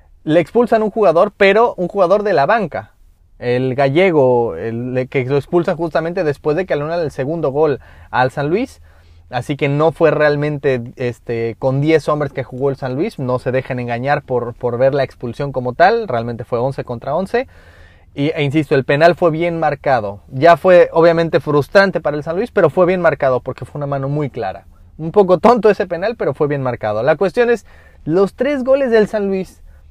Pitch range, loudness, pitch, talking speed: 125-175 Hz, -16 LUFS, 145 Hz, 205 wpm